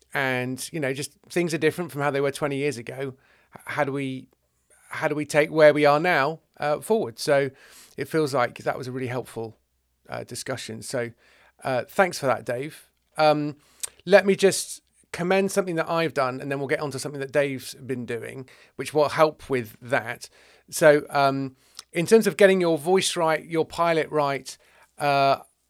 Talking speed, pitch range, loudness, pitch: 190 wpm, 130-160 Hz, -24 LUFS, 145 Hz